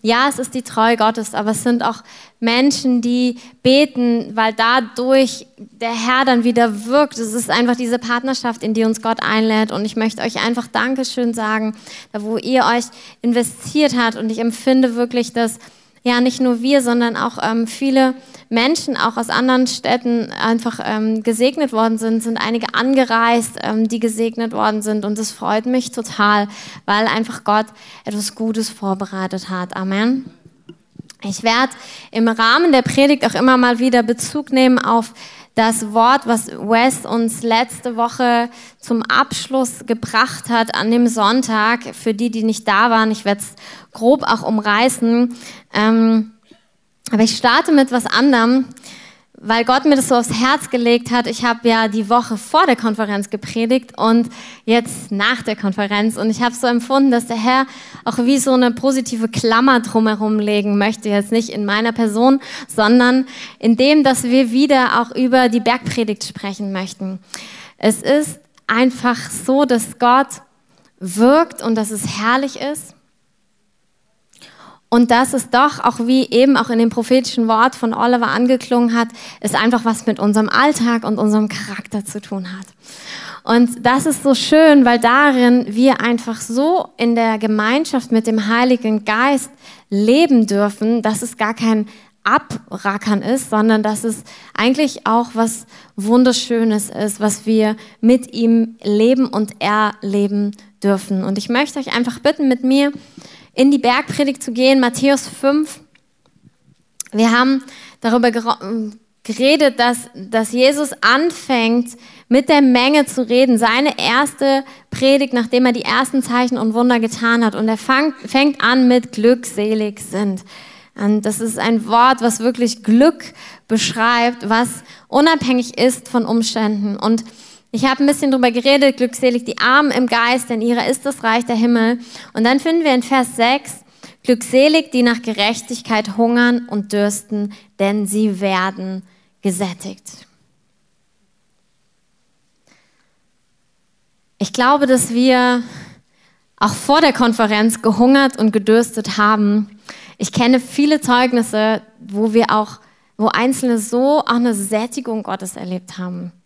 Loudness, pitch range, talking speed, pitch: -15 LUFS, 220-255 Hz, 150 wpm, 235 Hz